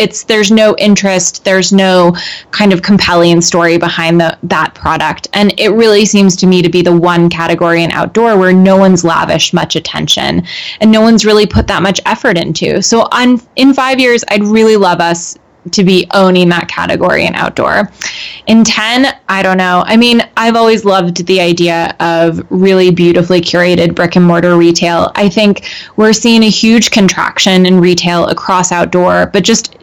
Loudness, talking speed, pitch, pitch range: -8 LUFS, 185 wpm, 185 Hz, 175-215 Hz